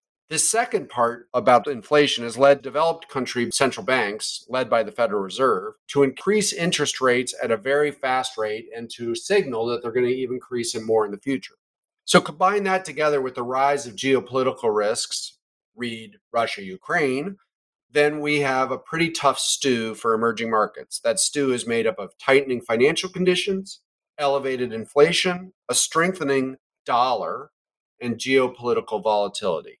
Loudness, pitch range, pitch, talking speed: -22 LUFS, 120-160 Hz, 135 Hz, 160 wpm